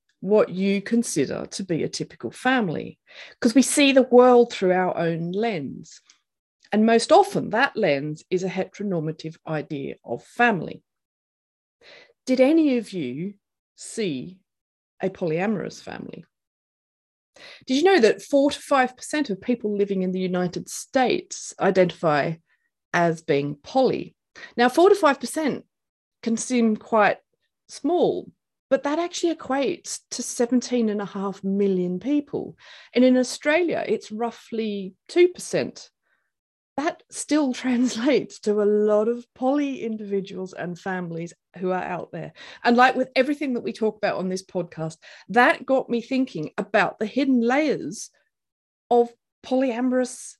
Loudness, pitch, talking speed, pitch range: -23 LUFS, 235 Hz, 135 wpm, 190-265 Hz